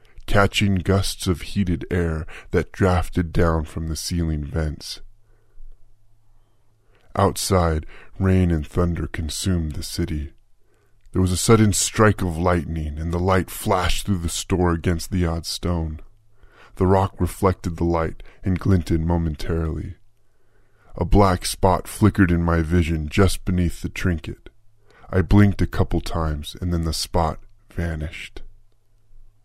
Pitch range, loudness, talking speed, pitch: 85-105 Hz, -22 LUFS, 135 wpm, 90 Hz